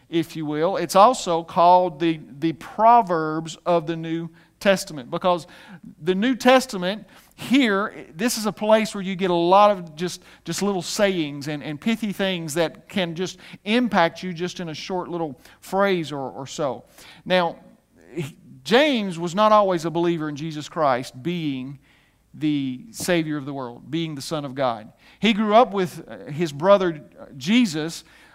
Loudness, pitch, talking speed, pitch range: -22 LUFS, 175 Hz, 165 wpm, 160-195 Hz